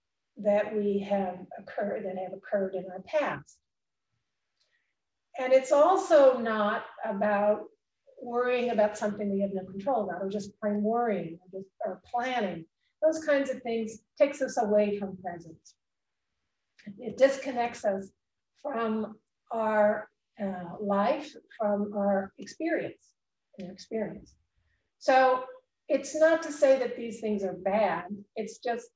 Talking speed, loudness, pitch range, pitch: 135 wpm, -29 LUFS, 195-250 Hz, 215 Hz